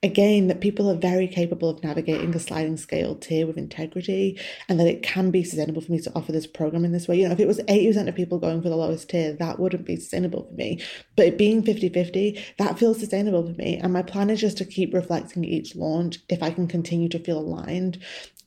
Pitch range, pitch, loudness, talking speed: 165-195 Hz, 180 Hz, -24 LUFS, 240 wpm